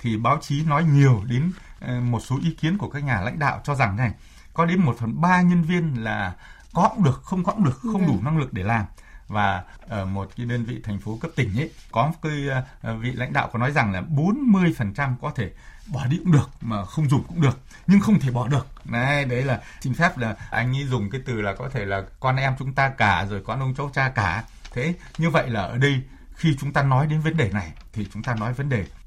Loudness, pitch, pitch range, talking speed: -23 LUFS, 130 Hz, 115-150 Hz, 260 wpm